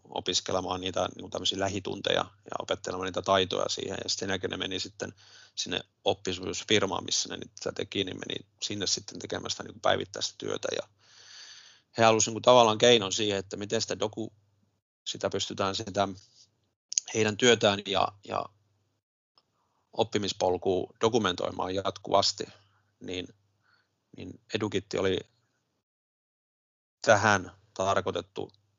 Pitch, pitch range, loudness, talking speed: 105 Hz, 95-110 Hz, -29 LUFS, 115 wpm